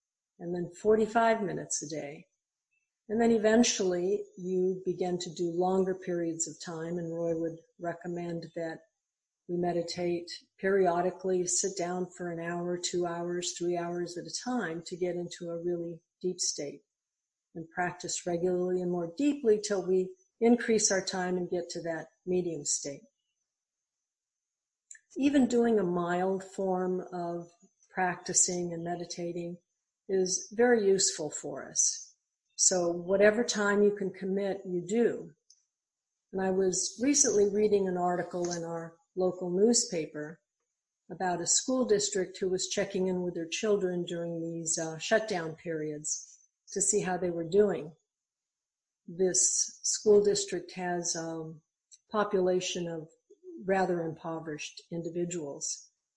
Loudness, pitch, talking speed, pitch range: -30 LUFS, 180 Hz, 135 wpm, 170-195 Hz